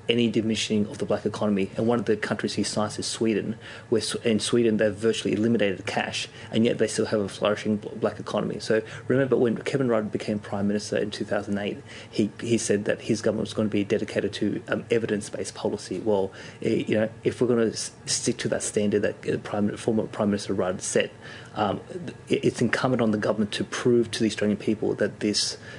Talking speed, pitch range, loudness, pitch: 205 wpm, 105-115 Hz, -26 LUFS, 110 Hz